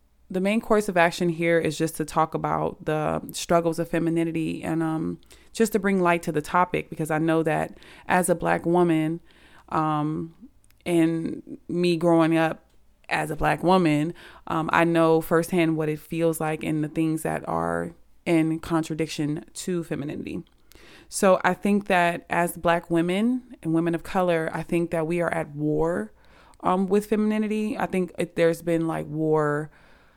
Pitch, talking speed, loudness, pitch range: 165 Hz, 170 wpm, -24 LUFS, 160-180 Hz